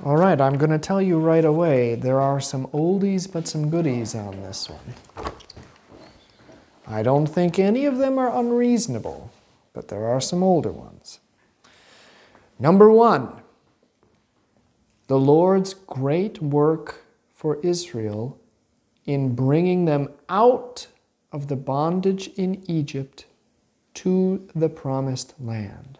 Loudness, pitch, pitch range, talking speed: -21 LUFS, 155 Hz, 135-185 Hz, 125 wpm